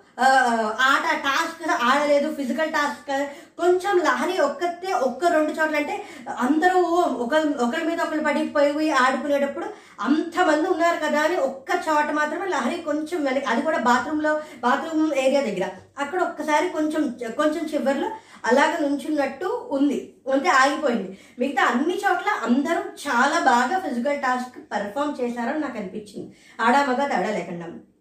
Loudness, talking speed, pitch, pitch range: -22 LUFS, 120 wpm, 295 Hz, 265-325 Hz